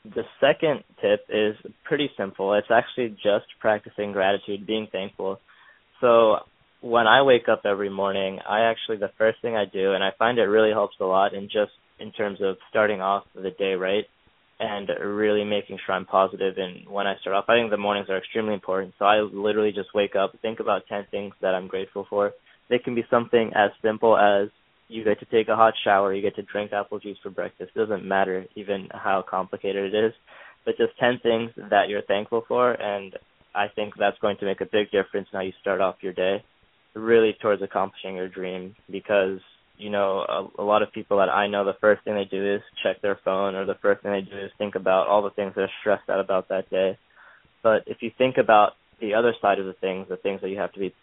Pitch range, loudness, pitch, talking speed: 95-110 Hz, -24 LUFS, 100 Hz, 225 wpm